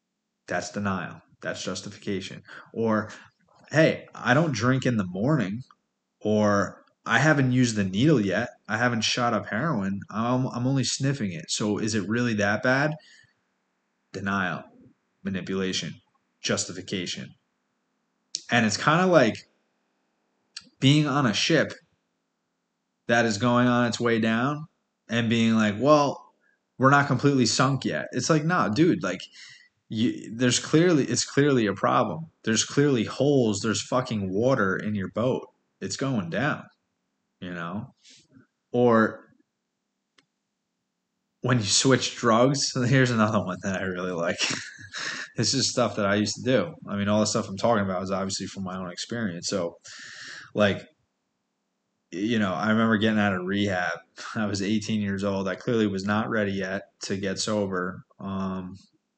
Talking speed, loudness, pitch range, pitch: 150 wpm, -25 LUFS, 100-130 Hz, 115 Hz